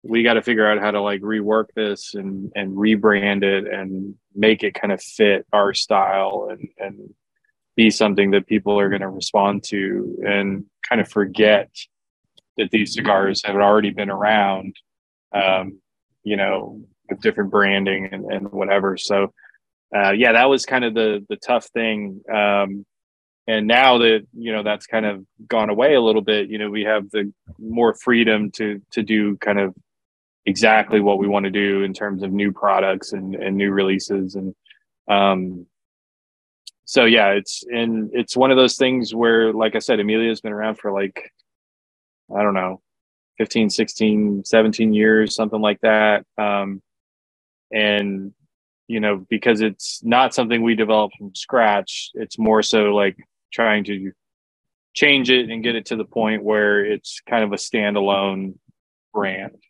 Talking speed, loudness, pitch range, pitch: 170 wpm, -19 LUFS, 100-110 Hz, 105 Hz